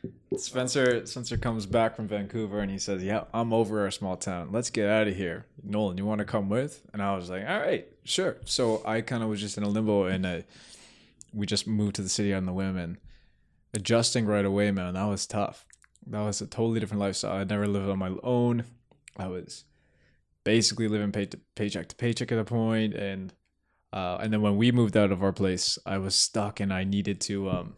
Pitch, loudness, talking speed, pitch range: 105 Hz, -28 LUFS, 225 wpm, 95-110 Hz